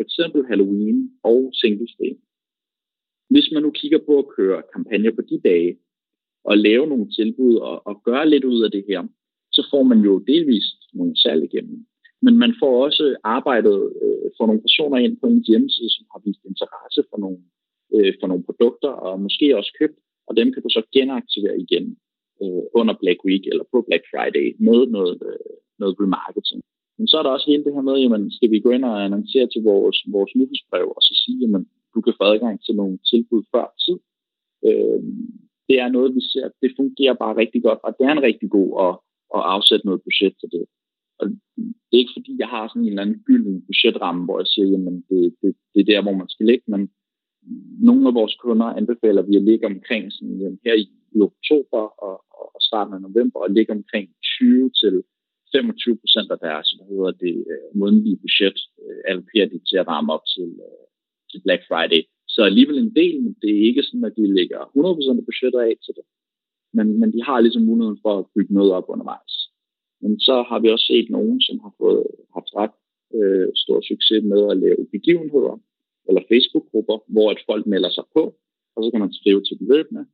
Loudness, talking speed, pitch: -18 LUFS, 205 wpm, 145 Hz